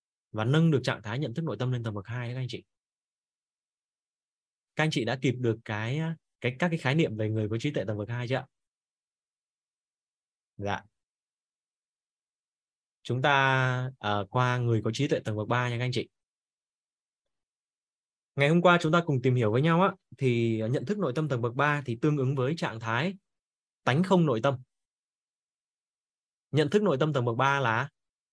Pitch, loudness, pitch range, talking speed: 130 Hz, -28 LUFS, 120-155 Hz, 195 wpm